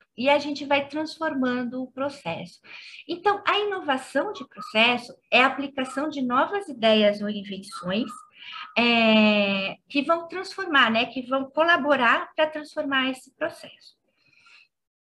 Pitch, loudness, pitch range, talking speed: 270 Hz, -23 LUFS, 235-310 Hz, 130 wpm